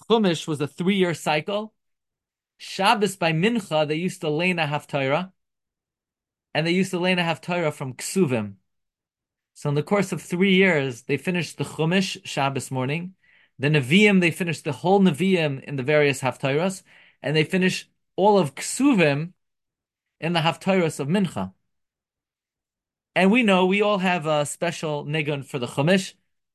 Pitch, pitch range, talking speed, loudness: 165 Hz, 145-185 Hz, 155 wpm, -22 LUFS